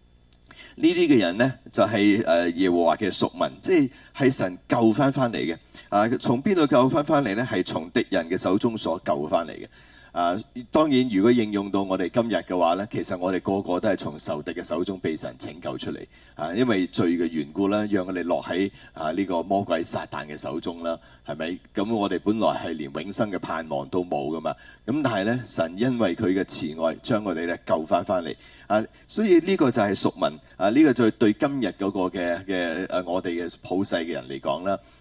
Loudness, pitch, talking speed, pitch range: -24 LUFS, 100 Hz, 300 characters per minute, 90-120 Hz